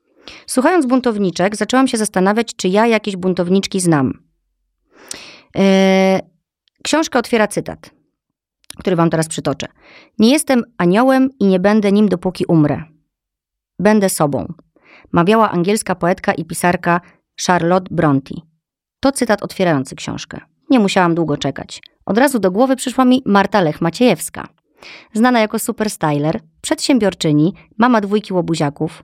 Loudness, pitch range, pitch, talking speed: -15 LUFS, 165-225 Hz, 190 Hz, 125 wpm